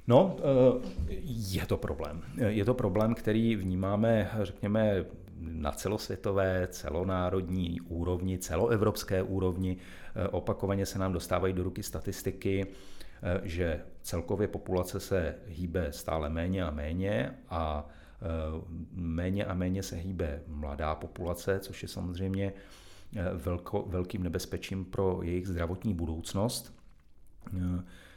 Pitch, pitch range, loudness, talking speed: 95 Hz, 85-100 Hz, -33 LUFS, 105 wpm